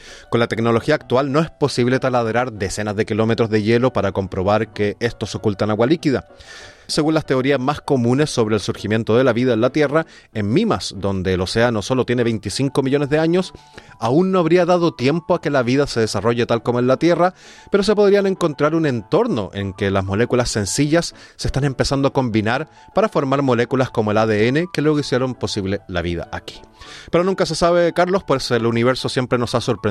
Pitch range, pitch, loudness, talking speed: 110-150 Hz, 125 Hz, -18 LUFS, 205 wpm